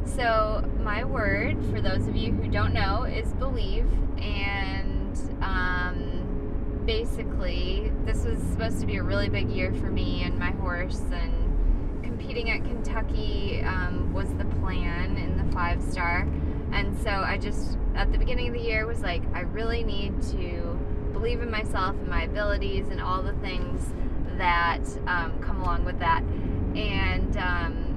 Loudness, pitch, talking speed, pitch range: -28 LUFS, 90 Hz, 160 wpm, 85-95 Hz